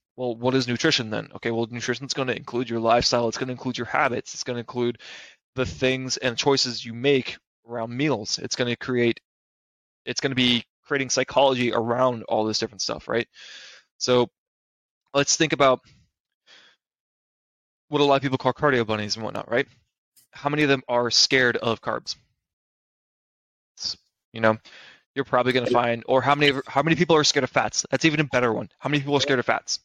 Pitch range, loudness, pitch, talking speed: 115-140 Hz, -23 LUFS, 125 Hz, 200 wpm